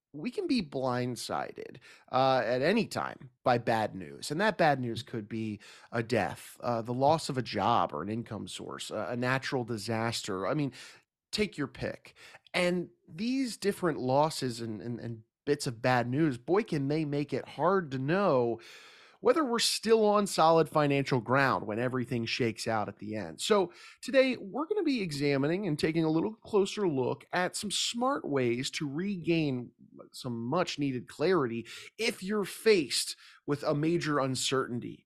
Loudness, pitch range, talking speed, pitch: -30 LUFS, 120-180 Hz, 170 wpm, 140 Hz